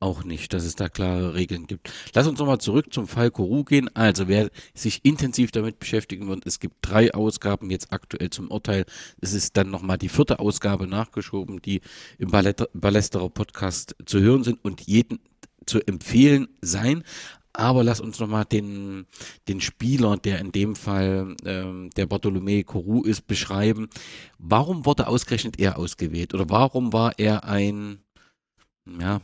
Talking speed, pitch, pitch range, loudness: 160 wpm, 105 Hz, 95-115 Hz, -23 LUFS